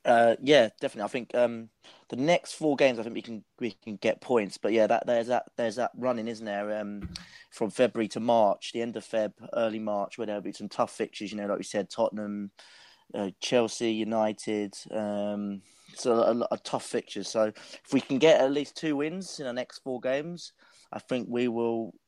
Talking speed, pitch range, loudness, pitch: 220 wpm, 105-125 Hz, -29 LUFS, 115 Hz